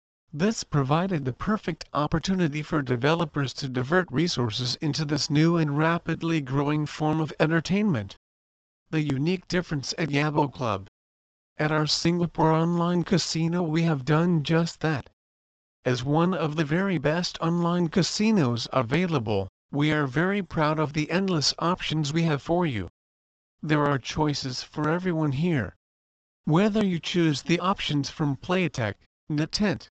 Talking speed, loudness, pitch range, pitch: 140 wpm, -26 LUFS, 135-170 Hz, 155 Hz